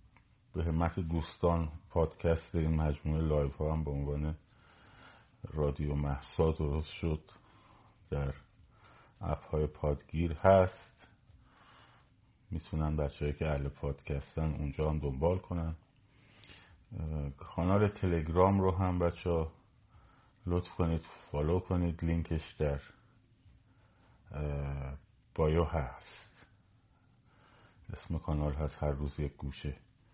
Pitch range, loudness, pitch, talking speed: 75-95 Hz, -34 LUFS, 80 Hz, 100 wpm